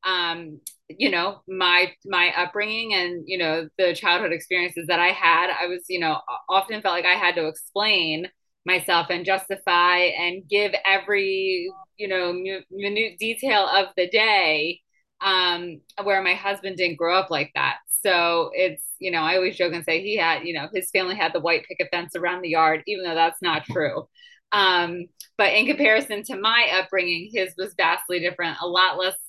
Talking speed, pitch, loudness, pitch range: 185 wpm, 185 Hz, -22 LUFS, 175-200 Hz